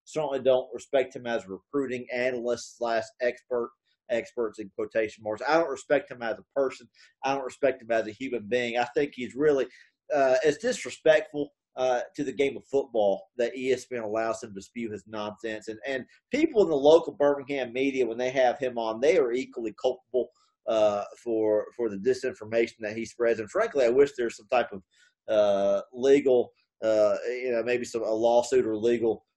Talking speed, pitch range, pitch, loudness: 190 wpm, 115-135 Hz, 125 Hz, -27 LUFS